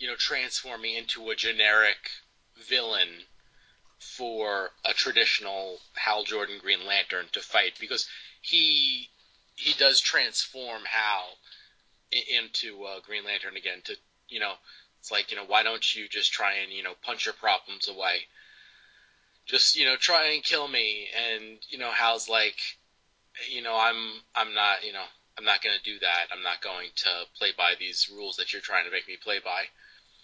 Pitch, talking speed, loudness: 115 Hz, 175 wpm, -26 LUFS